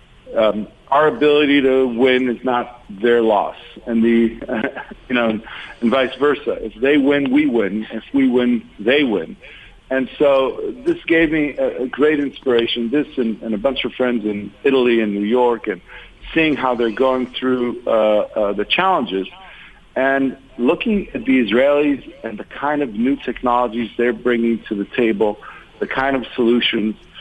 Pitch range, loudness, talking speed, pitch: 115-140 Hz, -18 LUFS, 170 wpm, 125 Hz